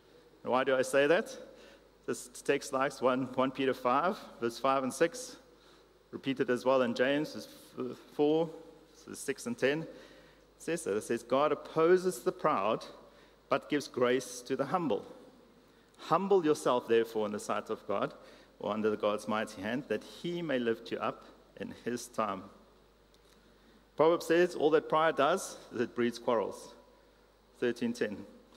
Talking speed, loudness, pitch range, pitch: 155 wpm, -32 LUFS, 125-185 Hz, 145 Hz